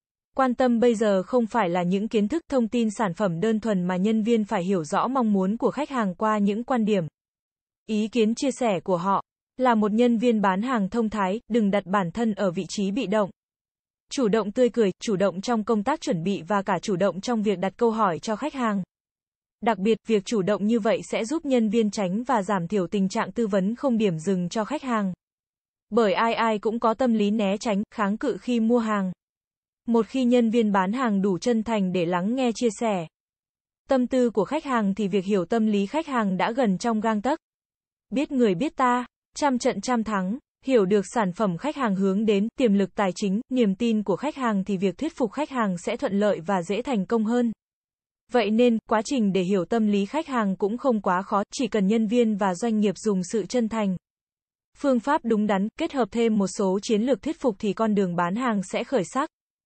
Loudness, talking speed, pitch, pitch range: -24 LUFS, 235 wpm, 220 Hz, 200-240 Hz